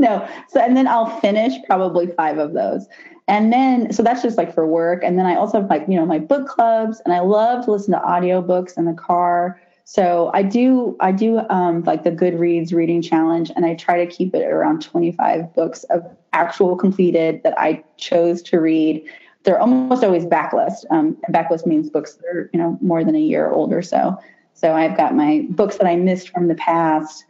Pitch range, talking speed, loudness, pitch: 170-230 Hz, 215 wpm, -18 LUFS, 180 Hz